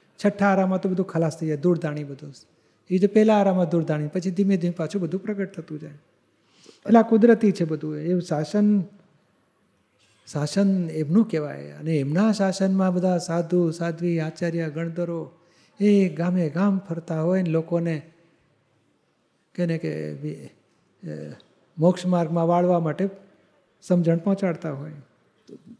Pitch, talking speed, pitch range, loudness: 170 Hz, 135 wpm, 155-190 Hz, -23 LUFS